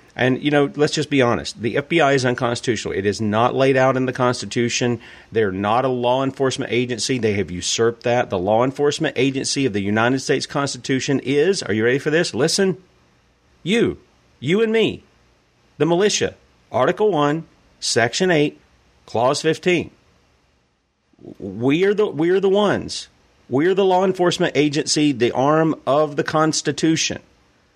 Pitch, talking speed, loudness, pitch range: 135 Hz, 160 wpm, -19 LUFS, 115-155 Hz